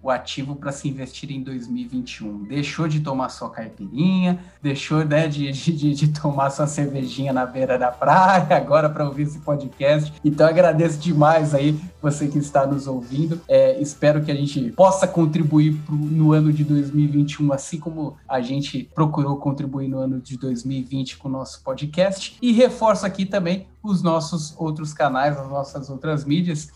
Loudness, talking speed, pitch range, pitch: -21 LUFS, 170 wpm, 140-165 Hz, 150 Hz